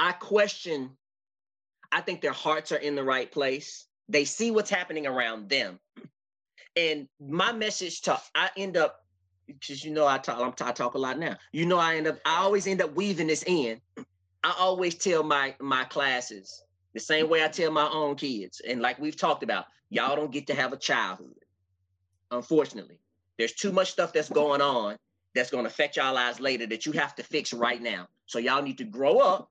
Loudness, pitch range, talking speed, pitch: -27 LUFS, 120-165 Hz, 200 wpm, 145 Hz